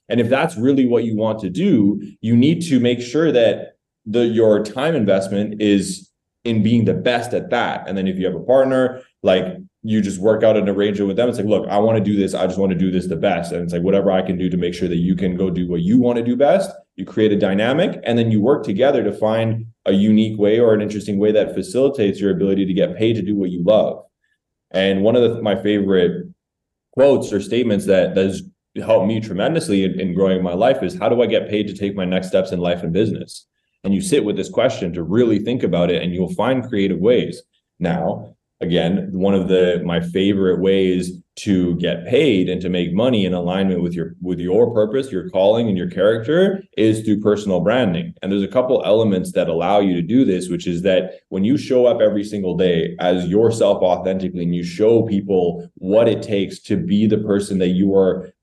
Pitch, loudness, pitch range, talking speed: 100 Hz, -18 LUFS, 90-110 Hz, 235 wpm